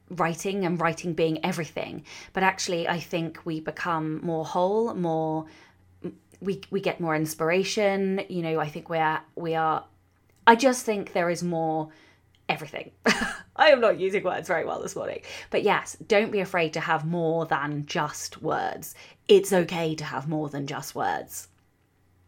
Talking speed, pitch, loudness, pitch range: 165 wpm, 165 Hz, -26 LUFS, 155-185 Hz